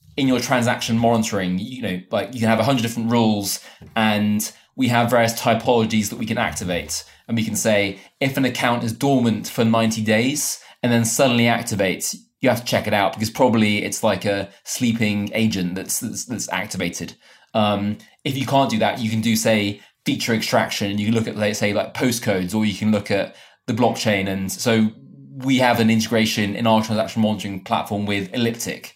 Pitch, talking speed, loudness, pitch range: 110 Hz, 200 wpm, -20 LUFS, 100-115 Hz